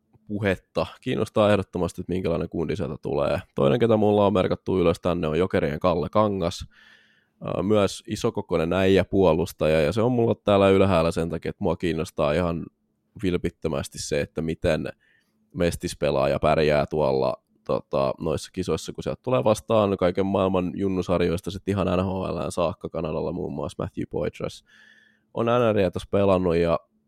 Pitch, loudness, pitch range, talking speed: 95 Hz, -24 LUFS, 85-105 Hz, 150 wpm